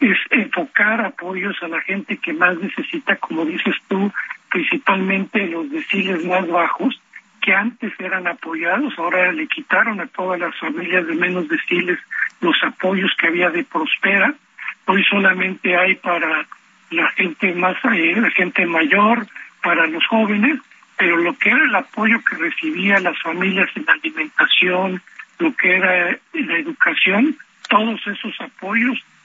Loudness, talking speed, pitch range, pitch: -17 LUFS, 145 wpm, 180-260 Hz, 195 Hz